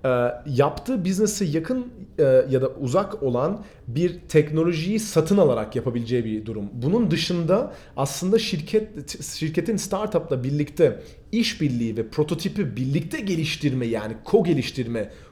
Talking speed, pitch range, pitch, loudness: 120 wpm, 130-195 Hz, 155 Hz, -23 LUFS